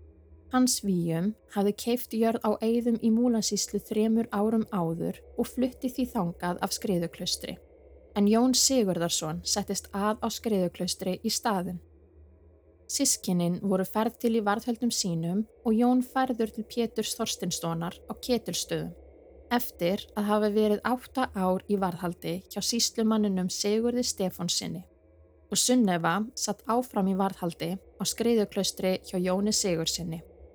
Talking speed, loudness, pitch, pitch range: 130 wpm, -28 LUFS, 205 Hz, 180-230 Hz